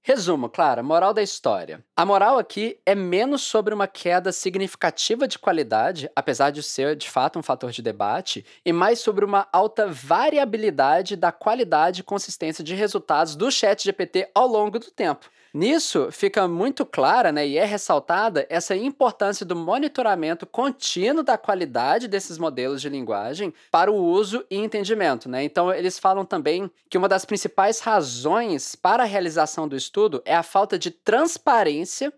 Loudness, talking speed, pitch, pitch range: -22 LUFS, 165 wpm, 200 Hz, 175-230 Hz